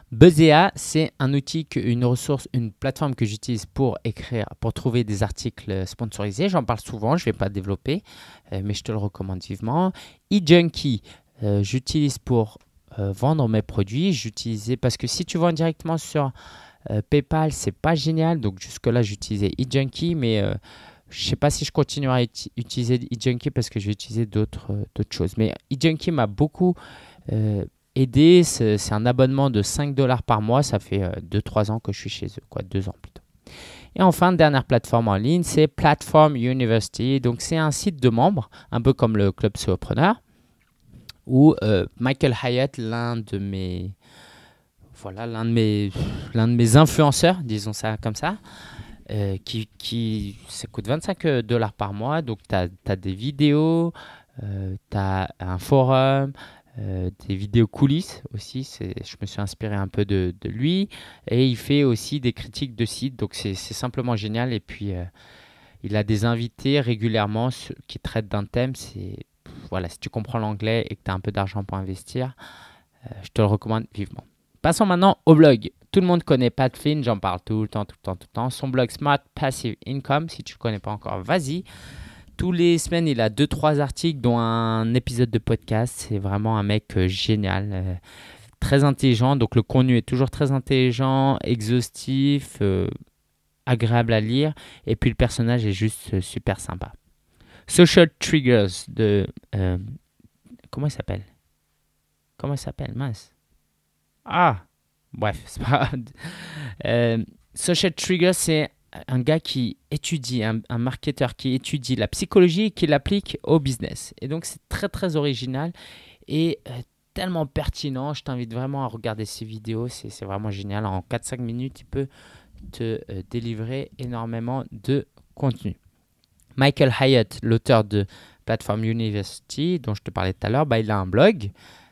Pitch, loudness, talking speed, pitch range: 120 Hz, -23 LUFS, 175 wpm, 105-140 Hz